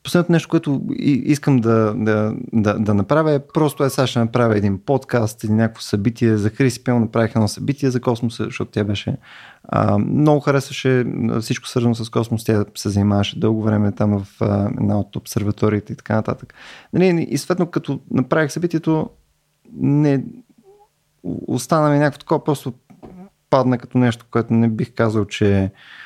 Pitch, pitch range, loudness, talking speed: 120 Hz, 110-145 Hz, -19 LUFS, 160 wpm